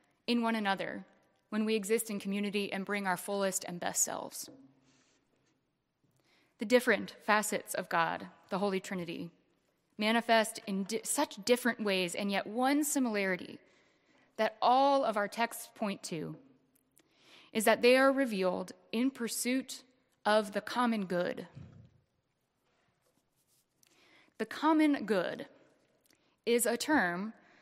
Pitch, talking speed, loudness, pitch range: 220 Hz, 125 wpm, -32 LUFS, 195-250 Hz